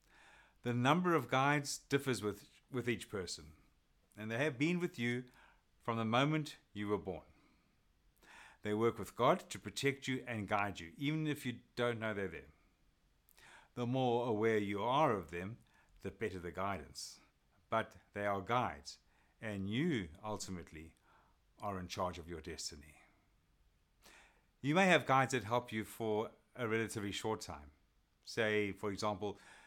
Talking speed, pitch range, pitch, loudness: 155 wpm, 95-120 Hz, 105 Hz, -38 LUFS